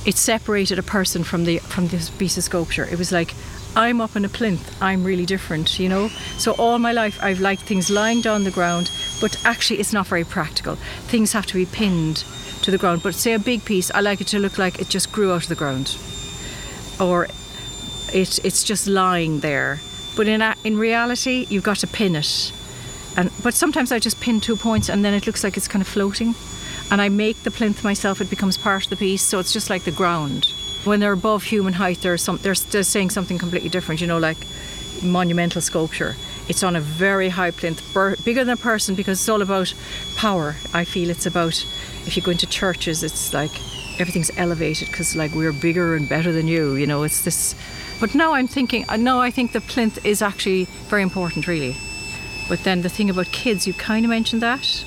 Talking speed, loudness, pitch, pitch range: 220 wpm, -20 LUFS, 190 Hz, 170-215 Hz